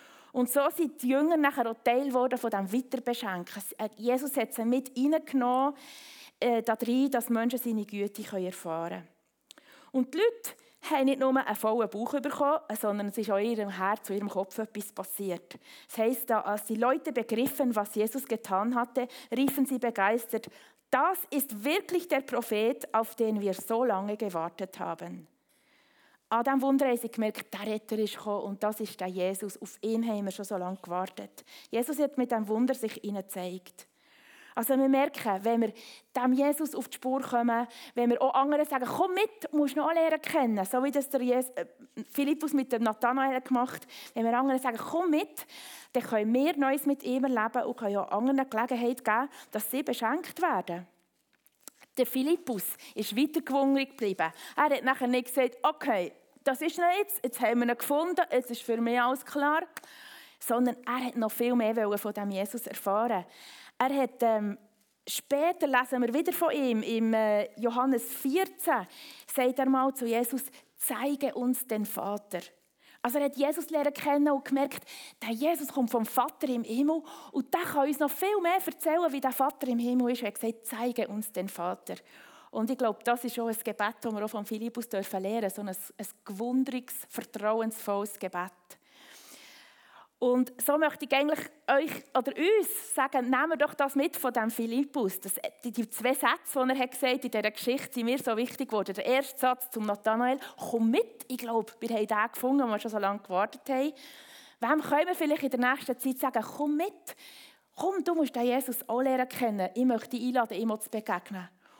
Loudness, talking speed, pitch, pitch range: -30 LUFS, 190 wpm, 250 Hz, 220-275 Hz